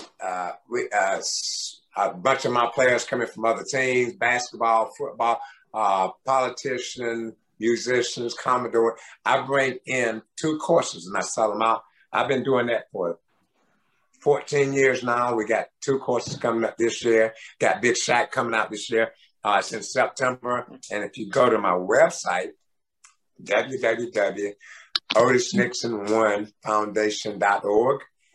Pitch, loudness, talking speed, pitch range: 115 Hz, -24 LUFS, 140 wpm, 110-125 Hz